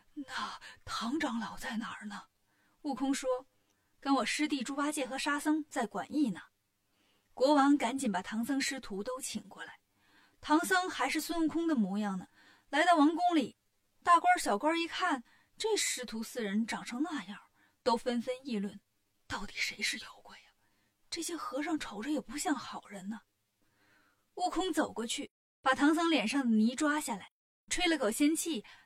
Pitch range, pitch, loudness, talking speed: 190-300 Hz, 255 Hz, -33 LUFS, 240 characters per minute